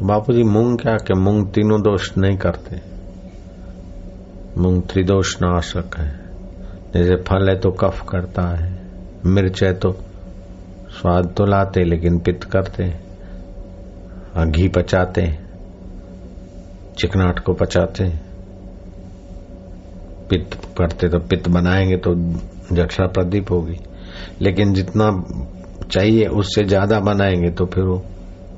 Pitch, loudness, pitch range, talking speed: 95 Hz, -18 LUFS, 90-95 Hz, 115 wpm